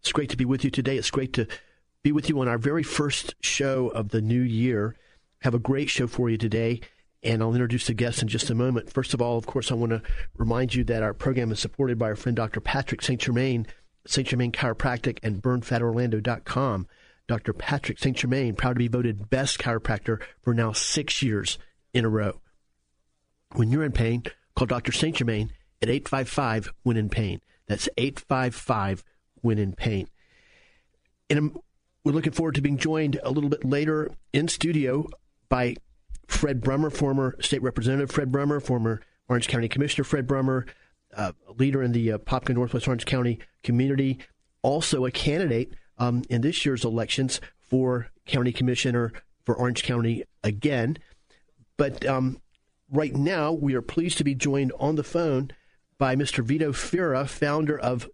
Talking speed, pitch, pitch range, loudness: 180 wpm, 125 Hz, 115-140 Hz, -26 LUFS